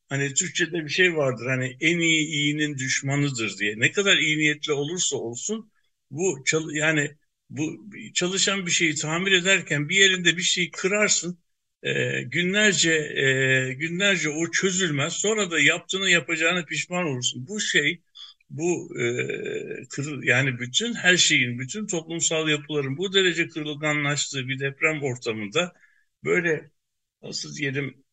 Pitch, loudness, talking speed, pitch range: 160 Hz, -23 LUFS, 135 wpm, 145-180 Hz